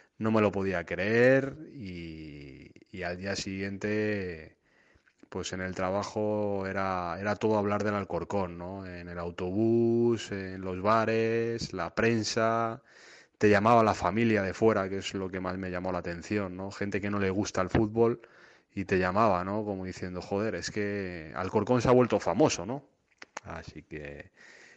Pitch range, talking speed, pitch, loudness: 90-110 Hz, 165 wpm, 100 Hz, -29 LUFS